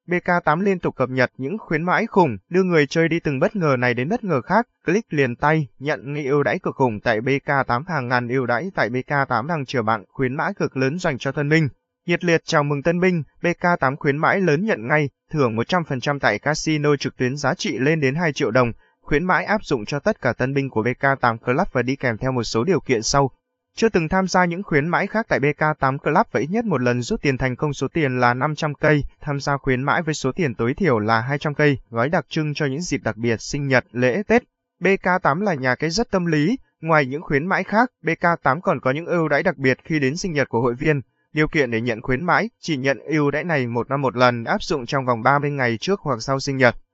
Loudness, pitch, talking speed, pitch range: -21 LUFS, 145 Hz, 250 wpm, 130-170 Hz